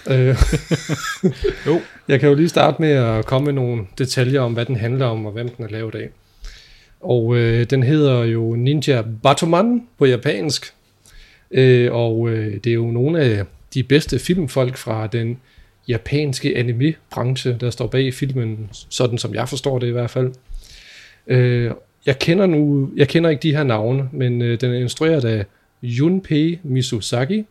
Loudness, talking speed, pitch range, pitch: -18 LUFS, 170 wpm, 120-145 Hz, 130 Hz